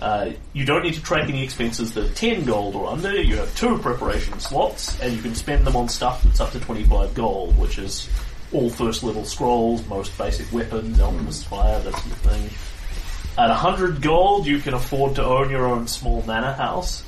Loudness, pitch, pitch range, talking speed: -22 LUFS, 120 Hz, 105-135 Hz, 210 wpm